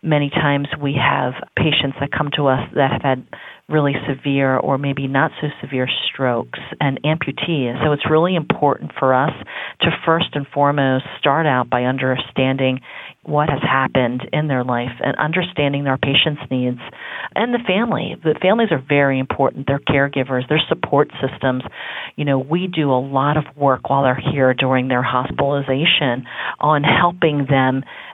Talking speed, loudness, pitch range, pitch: 165 wpm, -18 LUFS, 130-150 Hz, 140 Hz